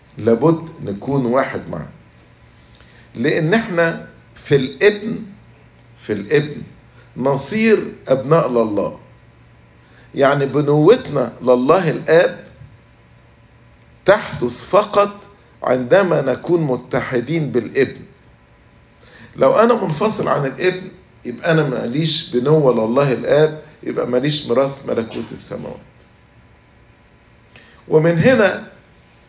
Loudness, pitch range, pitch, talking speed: -17 LUFS, 120-170 Hz, 140 Hz, 85 wpm